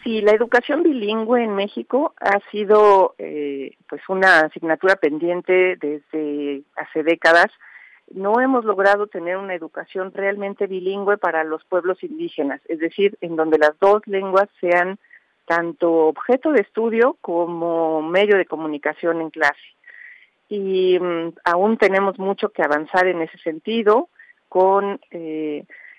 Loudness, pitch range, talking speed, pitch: -19 LUFS, 165-210 Hz, 130 wpm, 190 Hz